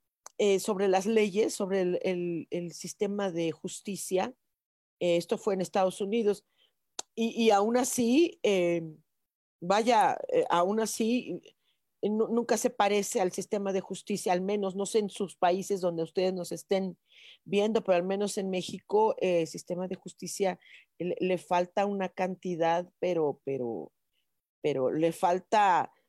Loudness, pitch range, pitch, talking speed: -29 LUFS, 180-210 Hz, 195 Hz, 150 wpm